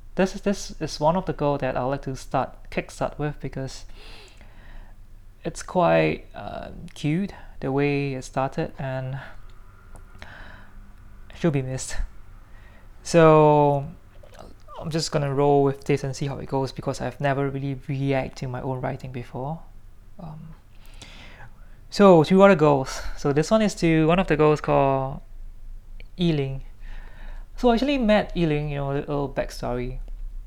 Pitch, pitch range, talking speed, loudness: 135 Hz, 105-150 Hz, 150 wpm, -23 LUFS